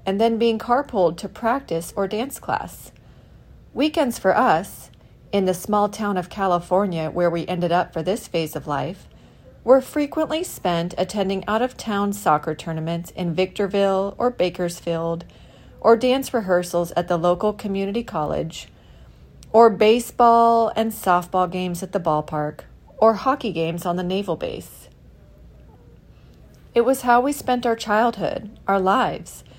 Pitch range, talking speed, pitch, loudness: 175-230 Hz, 145 wpm, 200 Hz, -21 LUFS